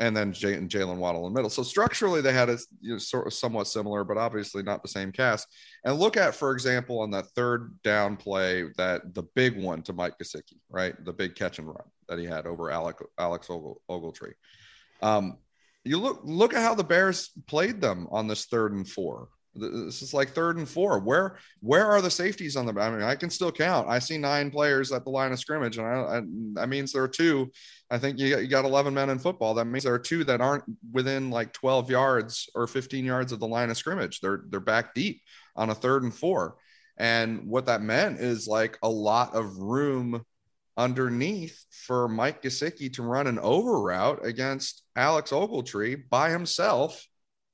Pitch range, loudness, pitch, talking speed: 105-135 Hz, -27 LUFS, 120 Hz, 215 wpm